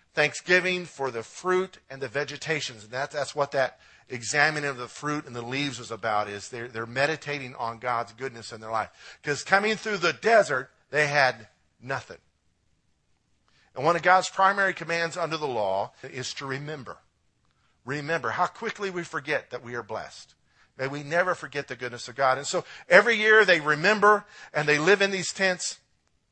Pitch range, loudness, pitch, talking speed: 125-180 Hz, -25 LUFS, 145 Hz, 180 wpm